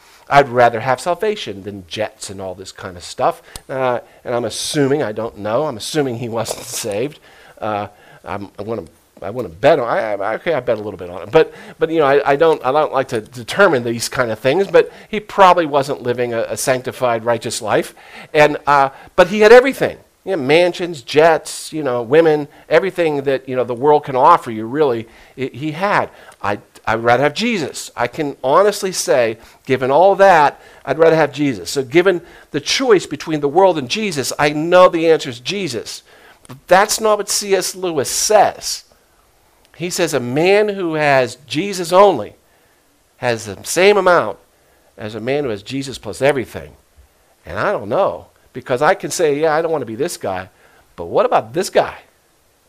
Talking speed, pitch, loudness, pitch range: 190 wpm, 145 Hz, -16 LUFS, 125-180 Hz